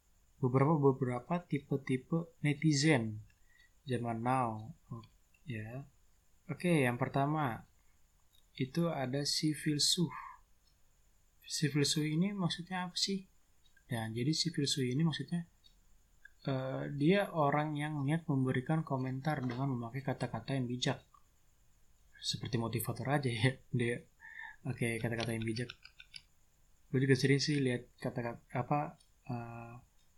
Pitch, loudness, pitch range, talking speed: 135 Hz, -35 LUFS, 120-150 Hz, 125 wpm